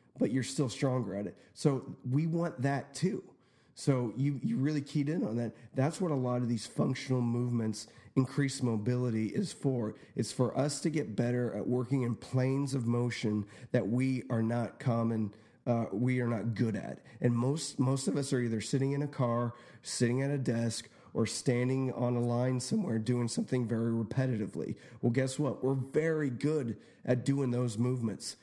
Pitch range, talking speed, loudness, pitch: 120-135 Hz, 195 wpm, -33 LUFS, 125 Hz